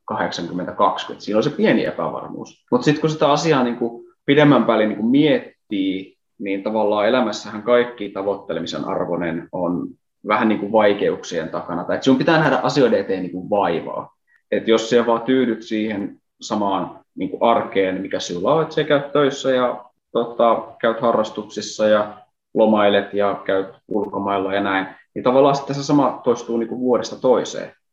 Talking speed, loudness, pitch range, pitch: 140 wpm, -19 LUFS, 100-130 Hz, 110 Hz